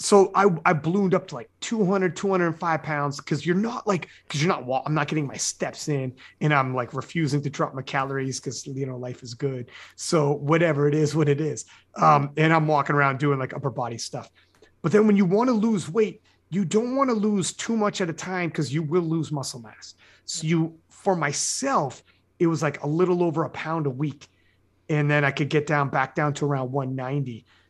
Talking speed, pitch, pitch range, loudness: 225 wpm, 150 Hz, 140-175 Hz, -24 LUFS